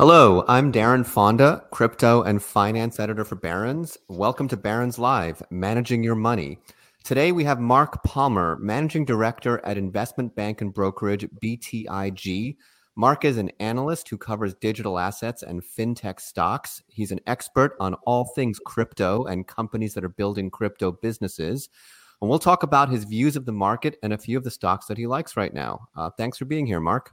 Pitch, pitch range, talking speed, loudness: 115 Hz, 100-125 Hz, 180 wpm, -23 LUFS